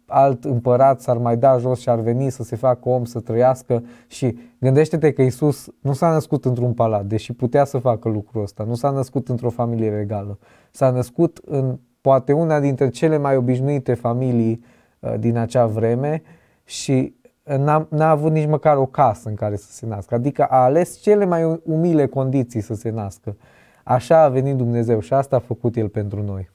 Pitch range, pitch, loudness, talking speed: 115-140 Hz, 125 Hz, -19 LUFS, 190 wpm